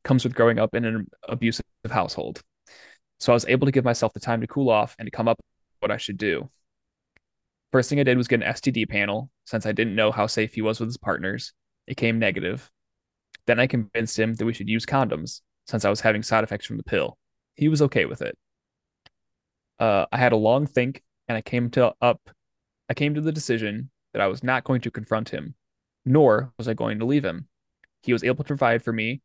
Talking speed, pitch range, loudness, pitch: 230 wpm, 110-130 Hz, -24 LUFS, 115 Hz